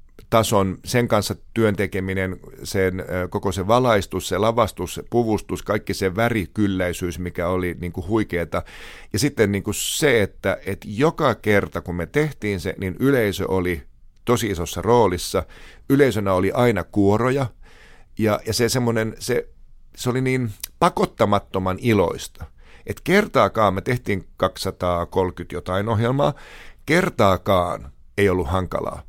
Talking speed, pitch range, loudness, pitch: 130 wpm, 90-115 Hz, -21 LUFS, 100 Hz